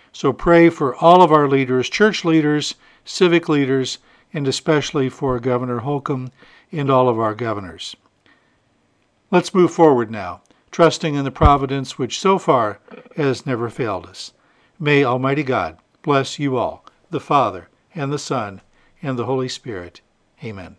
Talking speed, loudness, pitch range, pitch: 150 wpm, -18 LUFS, 130-160 Hz, 140 Hz